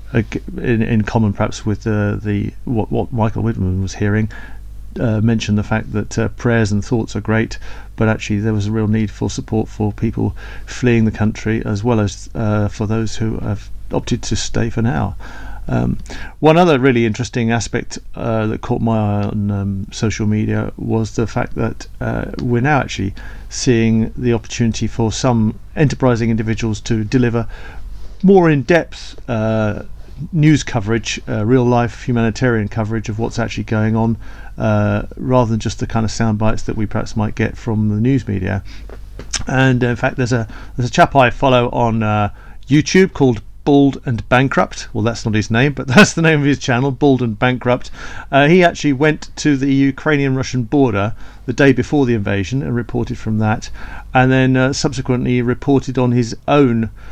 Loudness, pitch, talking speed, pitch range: -16 LUFS, 115 Hz, 180 wpm, 105-125 Hz